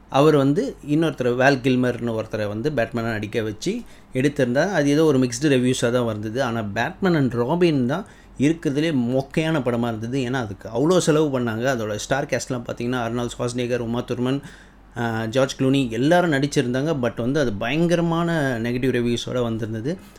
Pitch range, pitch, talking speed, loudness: 120-150 Hz, 130 Hz, 150 wpm, -22 LUFS